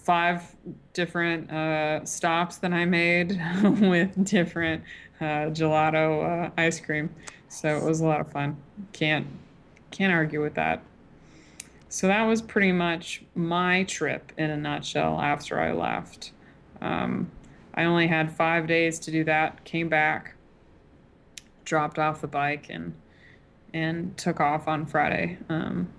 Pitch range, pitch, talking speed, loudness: 155-175 Hz, 160 Hz, 140 wpm, -26 LUFS